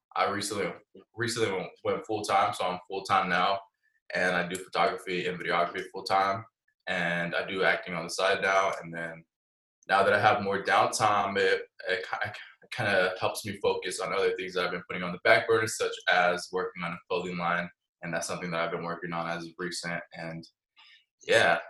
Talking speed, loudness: 205 wpm, -28 LUFS